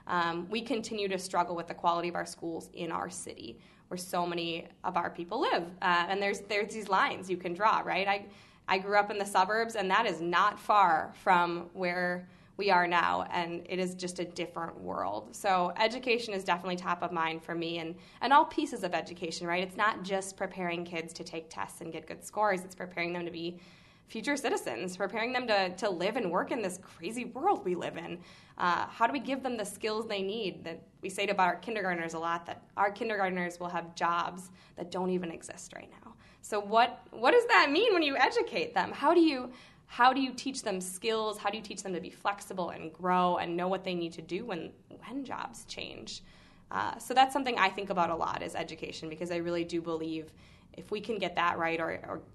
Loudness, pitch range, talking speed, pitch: -31 LUFS, 170-215 Hz, 230 wpm, 185 Hz